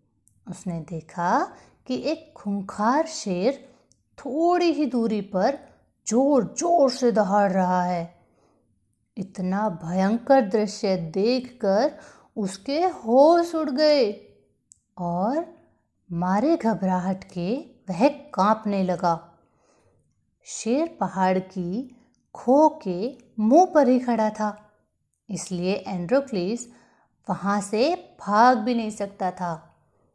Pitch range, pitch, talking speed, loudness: 185-270 Hz, 215 Hz, 100 wpm, -23 LUFS